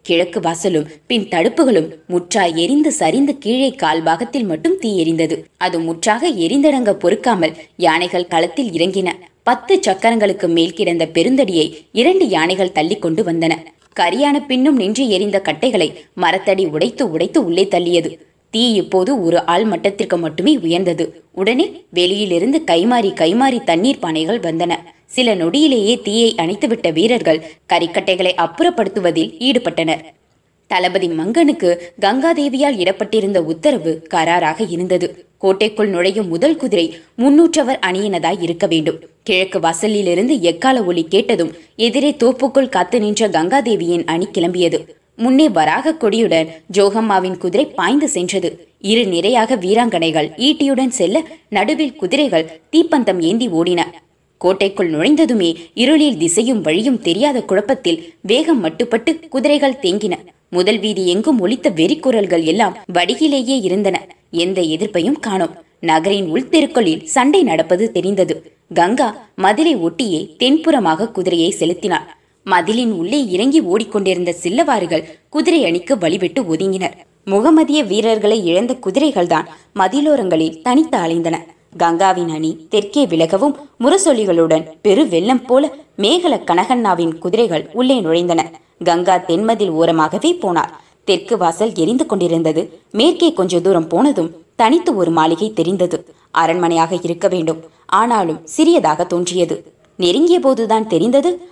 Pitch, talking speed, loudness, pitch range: 195 Hz, 110 wpm, -15 LUFS, 170-265 Hz